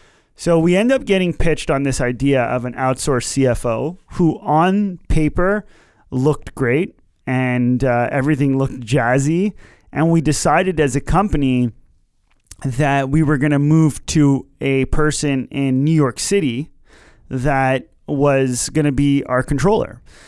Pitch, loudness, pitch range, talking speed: 140 Hz, -17 LUFS, 130-155 Hz, 145 wpm